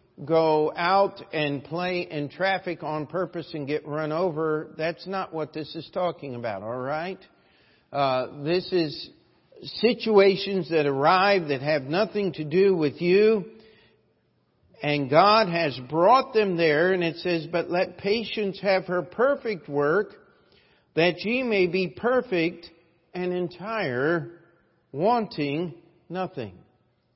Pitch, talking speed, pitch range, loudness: 170 Hz, 130 wpm, 155-195 Hz, -25 LUFS